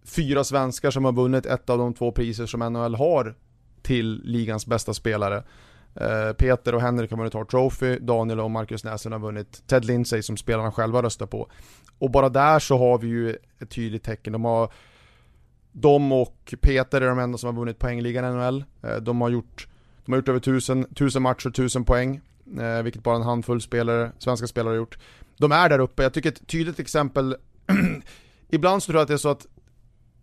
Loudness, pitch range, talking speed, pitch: -24 LUFS, 115-130 Hz, 200 wpm, 120 Hz